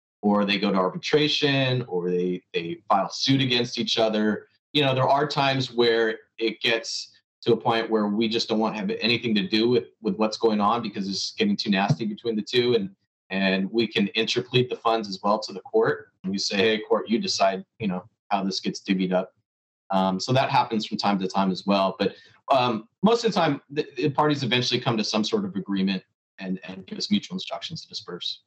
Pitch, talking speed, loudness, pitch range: 110 Hz, 225 wpm, -24 LUFS, 95-130 Hz